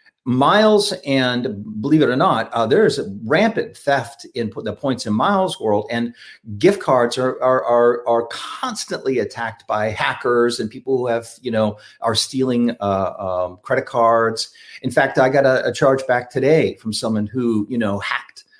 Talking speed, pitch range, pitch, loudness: 180 wpm, 110-130 Hz, 120 Hz, -19 LUFS